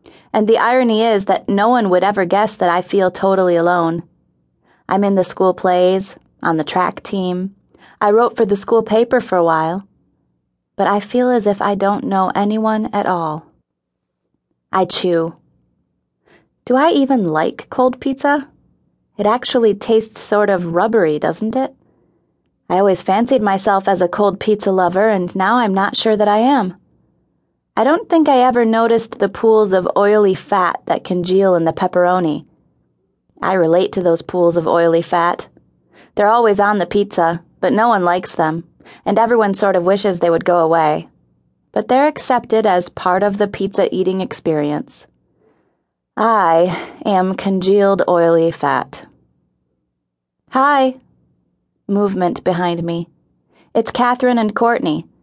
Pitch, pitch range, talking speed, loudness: 195 Hz, 170-220 Hz, 155 wpm, -15 LUFS